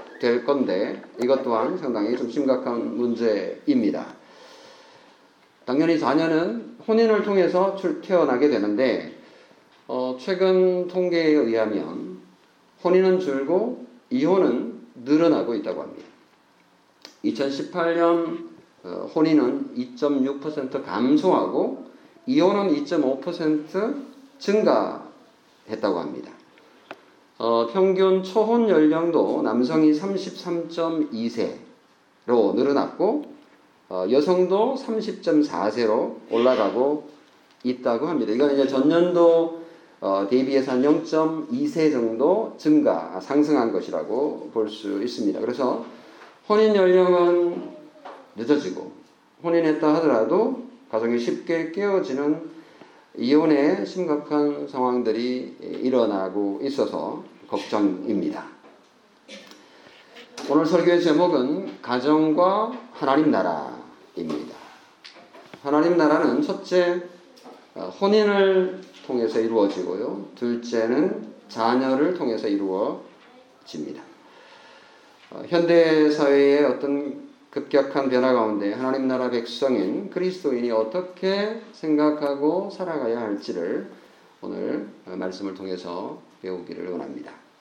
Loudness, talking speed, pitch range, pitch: -22 LUFS, 215 characters per minute, 130-190 Hz, 160 Hz